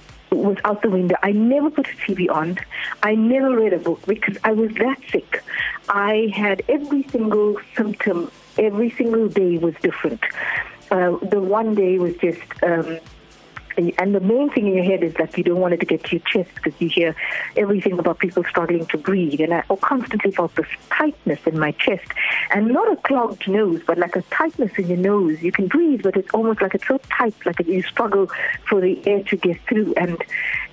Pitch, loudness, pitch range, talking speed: 195 Hz, -20 LUFS, 175-220 Hz, 205 wpm